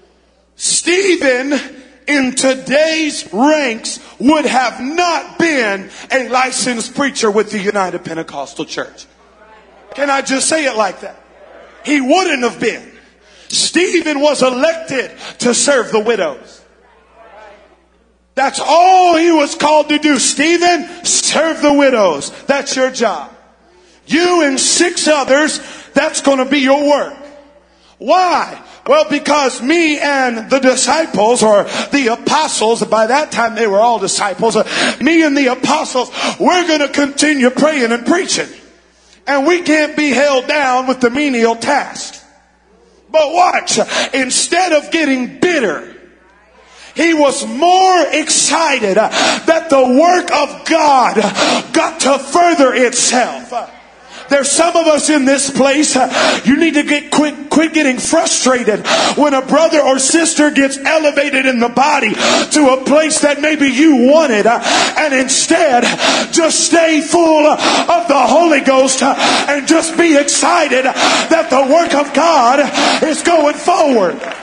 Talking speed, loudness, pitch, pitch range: 135 wpm, -12 LUFS, 285 Hz, 255-315 Hz